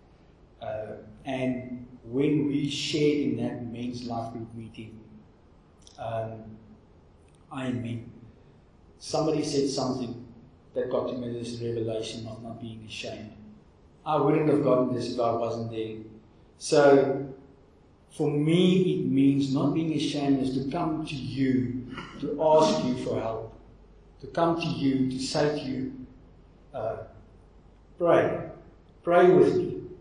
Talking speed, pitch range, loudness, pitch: 135 wpm, 110-145 Hz, -27 LUFS, 125 Hz